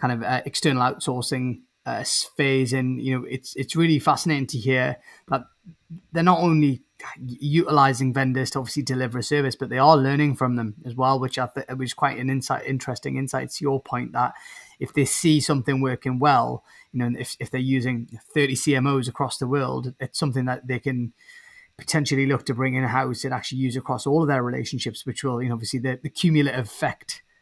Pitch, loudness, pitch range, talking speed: 130 Hz, -23 LUFS, 130-145 Hz, 205 wpm